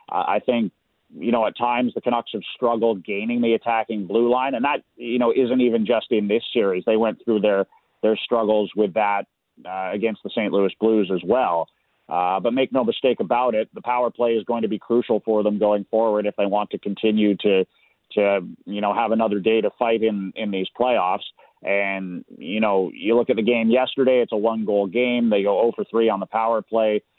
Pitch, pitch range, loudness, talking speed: 110 Hz, 100-115 Hz, -21 LUFS, 220 wpm